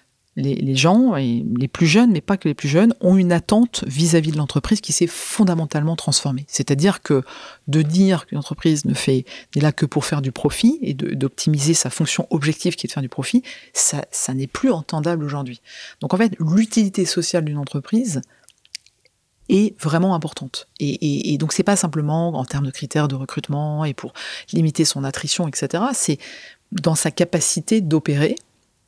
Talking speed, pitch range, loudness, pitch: 185 wpm, 145-185 Hz, -19 LUFS, 160 Hz